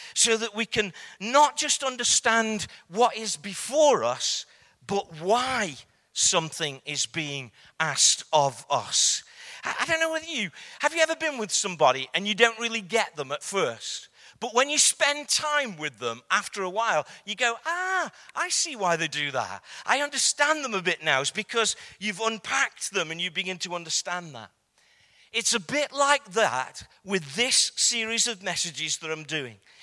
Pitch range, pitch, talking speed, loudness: 170-265 Hz, 220 Hz, 175 wpm, -25 LUFS